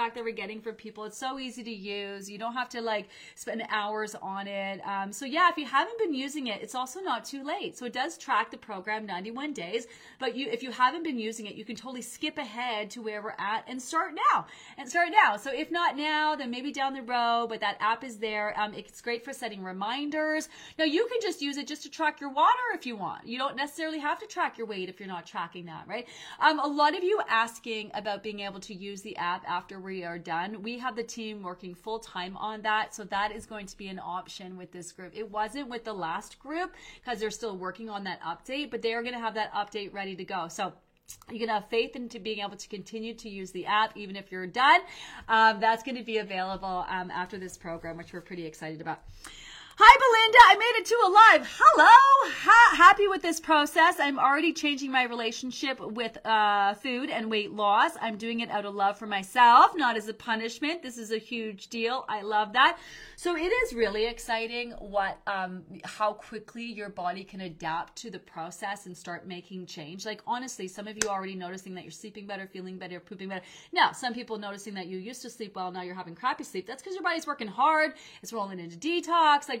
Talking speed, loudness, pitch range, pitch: 235 wpm, -26 LUFS, 200-275 Hz, 225 Hz